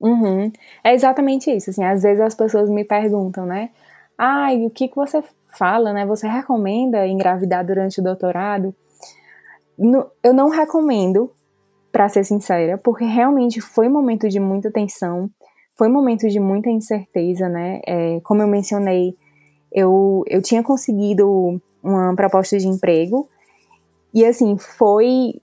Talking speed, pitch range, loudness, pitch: 150 wpm, 190-240 Hz, -17 LUFS, 205 Hz